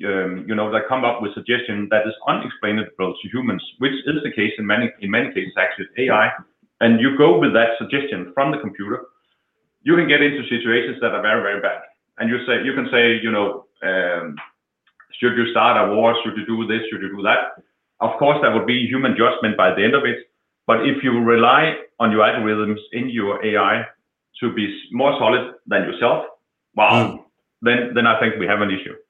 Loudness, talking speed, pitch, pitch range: -18 LUFS, 210 wpm, 115 Hz, 105-125 Hz